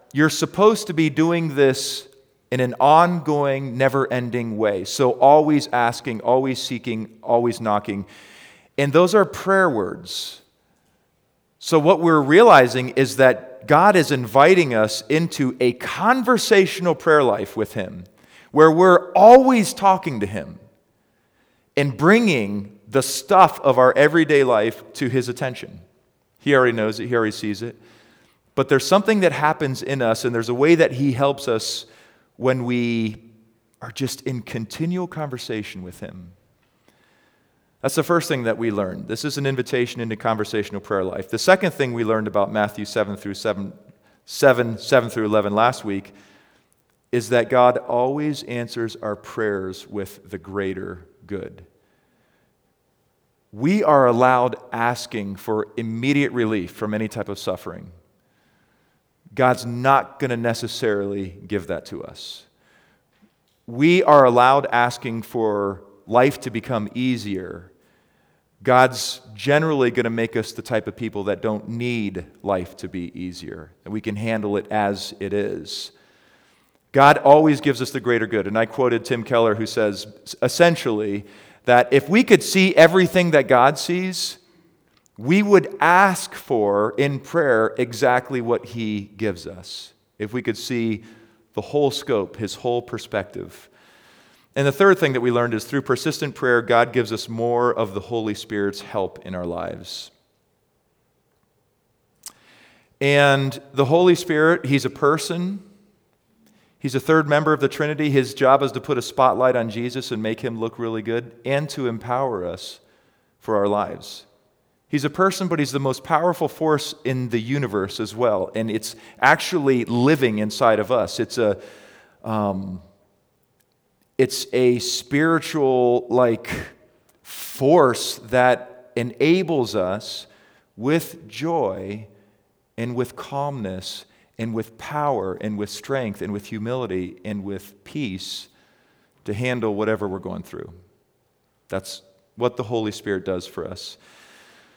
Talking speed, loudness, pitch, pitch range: 145 wpm, -20 LUFS, 125 Hz, 110-145 Hz